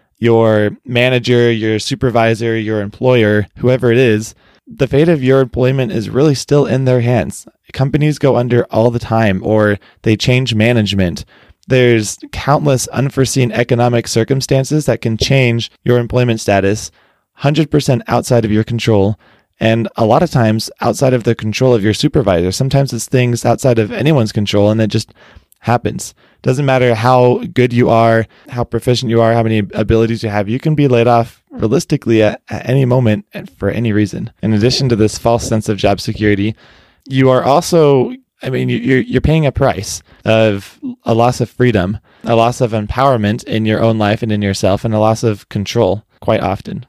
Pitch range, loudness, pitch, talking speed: 110-130 Hz, -13 LUFS, 115 Hz, 180 wpm